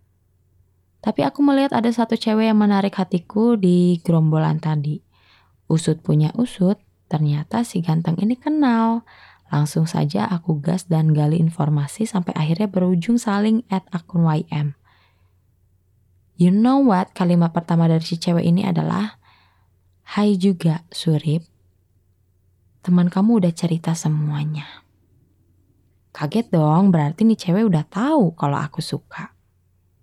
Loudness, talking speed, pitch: -19 LUFS, 125 wpm, 165 Hz